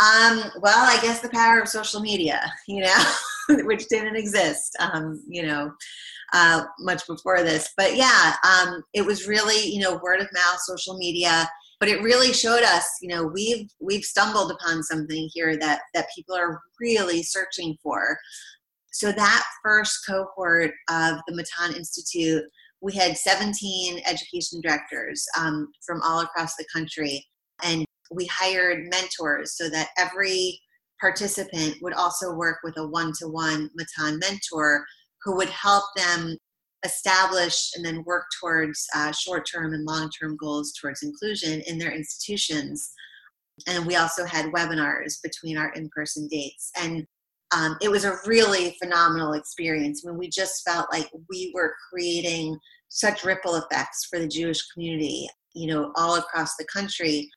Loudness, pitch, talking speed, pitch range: -23 LUFS, 170 Hz, 155 wpm, 160-190 Hz